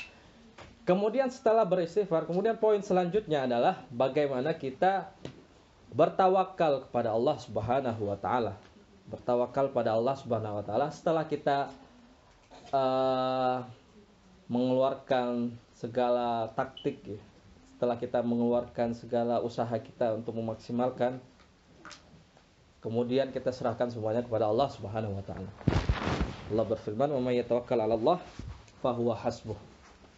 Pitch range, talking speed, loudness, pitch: 115-140 Hz, 100 wpm, -30 LUFS, 125 Hz